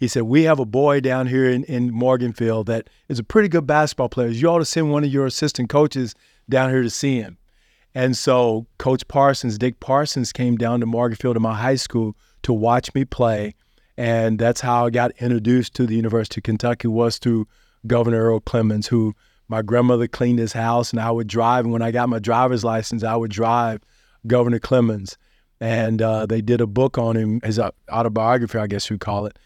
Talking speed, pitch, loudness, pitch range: 210 wpm, 120 Hz, -20 LUFS, 115-125 Hz